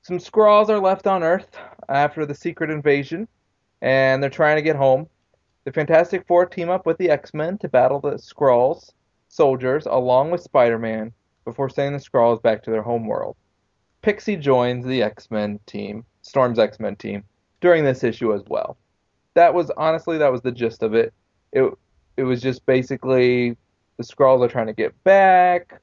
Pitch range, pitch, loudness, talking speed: 120-170 Hz, 135 Hz, -19 LUFS, 170 wpm